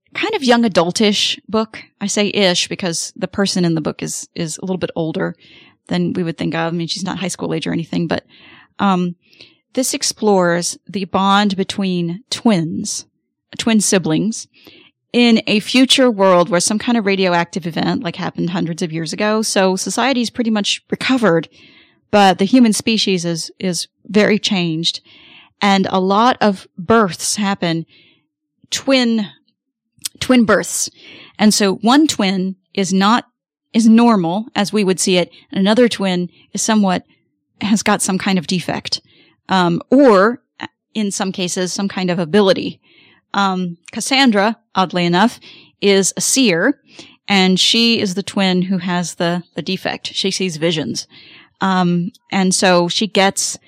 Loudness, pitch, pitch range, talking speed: -16 LUFS, 195 Hz, 180-220 Hz, 160 wpm